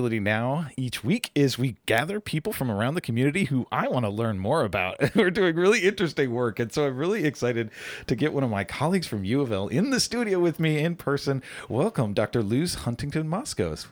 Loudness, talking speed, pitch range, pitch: -26 LUFS, 205 wpm, 120-165 Hz, 140 Hz